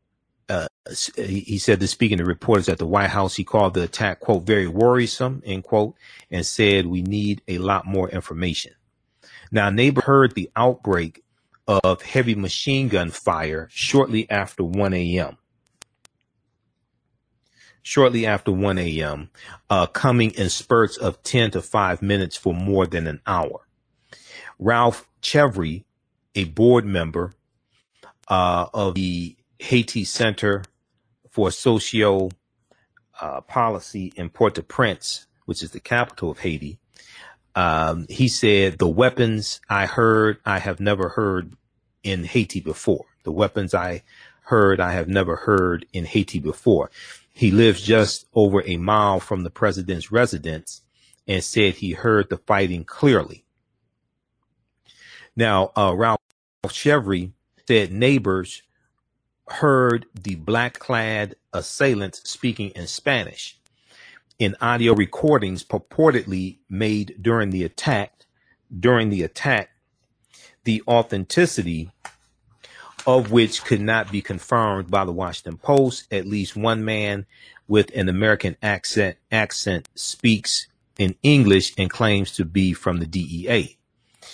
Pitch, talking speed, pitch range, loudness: 100 Hz, 130 wpm, 95-115 Hz, -21 LUFS